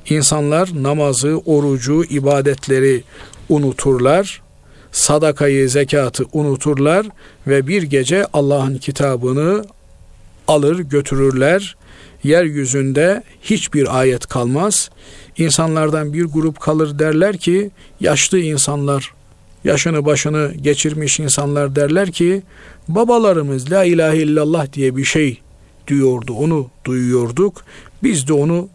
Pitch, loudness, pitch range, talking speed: 145 Hz, -15 LUFS, 135-160 Hz, 95 wpm